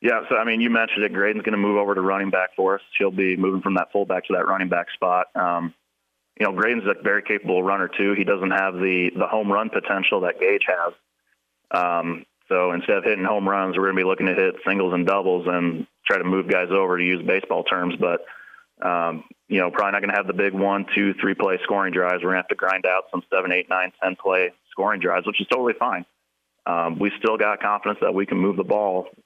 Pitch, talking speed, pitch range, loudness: 95 Hz, 240 wpm, 90-100 Hz, -22 LUFS